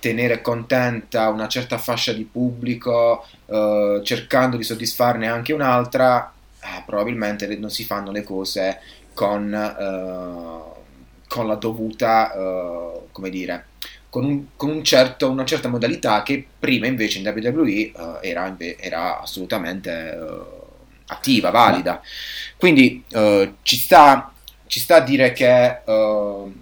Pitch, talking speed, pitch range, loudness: 115 Hz, 115 wpm, 105-130 Hz, -19 LUFS